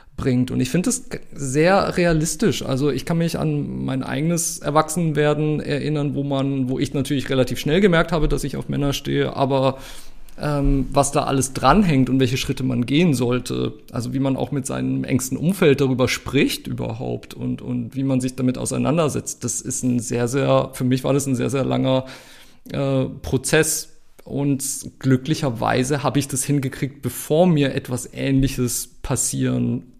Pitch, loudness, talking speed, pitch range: 135 Hz, -21 LUFS, 170 wpm, 130-145 Hz